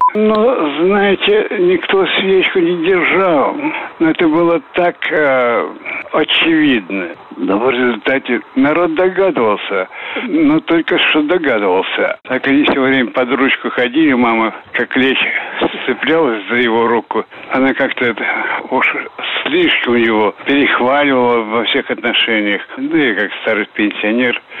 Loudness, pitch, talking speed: -13 LUFS, 170 Hz, 120 wpm